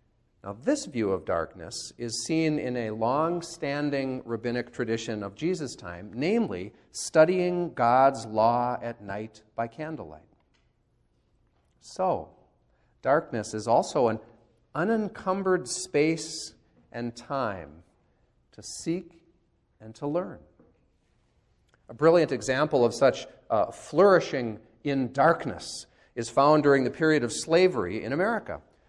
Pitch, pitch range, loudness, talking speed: 130 Hz, 115-160 Hz, -27 LUFS, 115 wpm